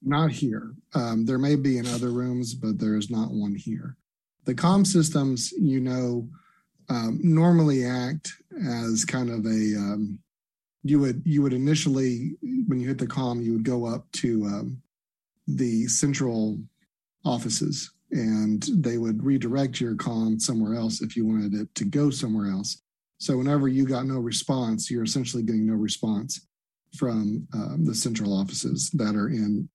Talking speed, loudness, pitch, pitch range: 165 wpm, -26 LUFS, 125 Hz, 110-140 Hz